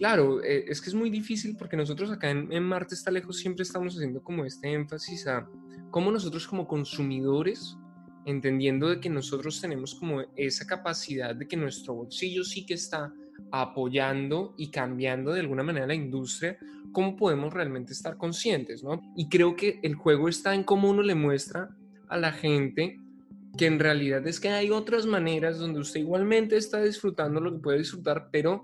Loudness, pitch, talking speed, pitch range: -29 LUFS, 160 Hz, 180 wpm, 140-185 Hz